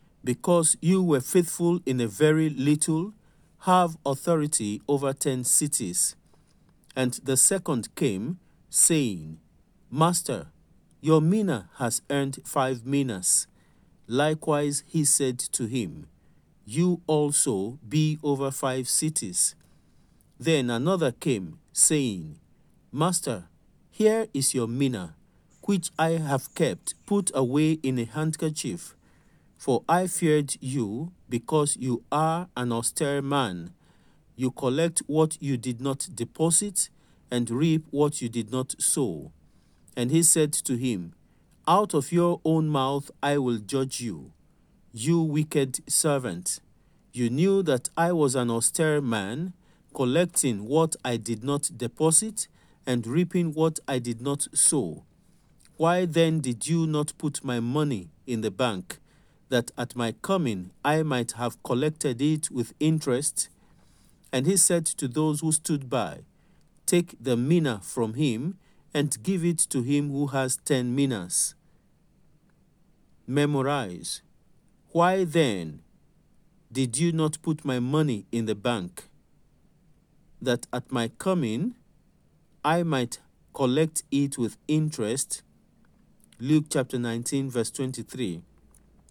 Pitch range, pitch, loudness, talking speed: 125-160 Hz, 140 Hz, -26 LUFS, 125 wpm